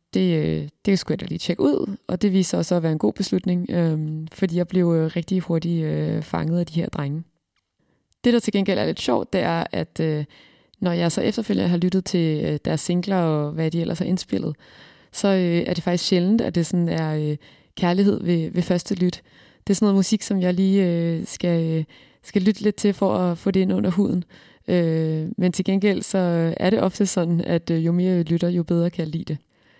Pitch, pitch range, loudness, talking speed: 175 Hz, 165-190 Hz, -22 LUFS, 230 wpm